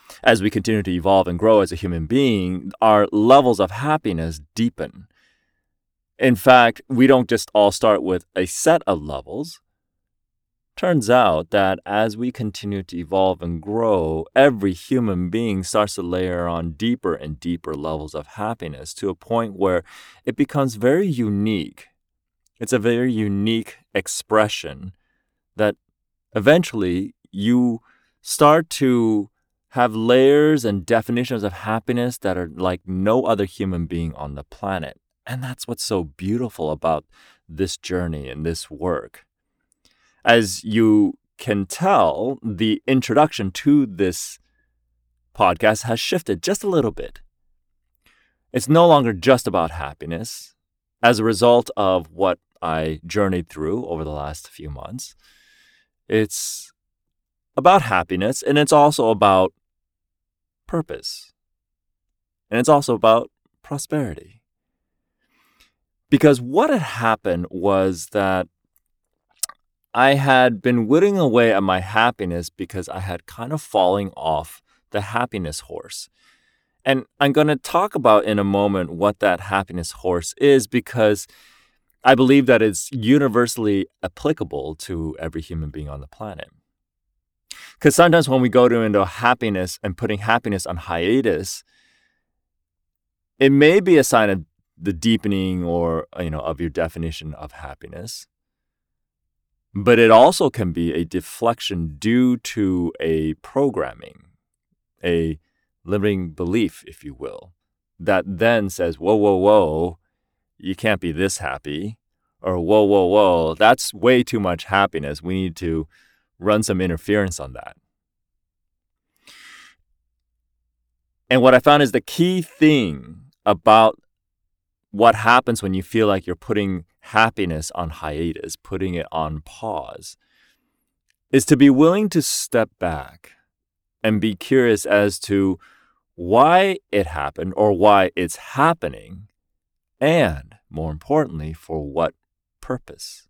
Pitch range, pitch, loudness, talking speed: 85-120 Hz, 100 Hz, -19 LUFS, 135 wpm